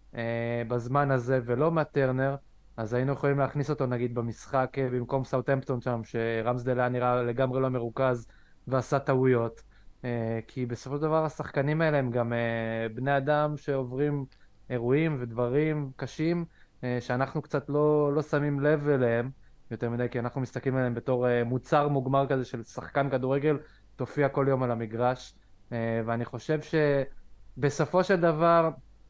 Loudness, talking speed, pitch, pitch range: -28 LUFS, 135 wpm, 130 Hz, 120-145 Hz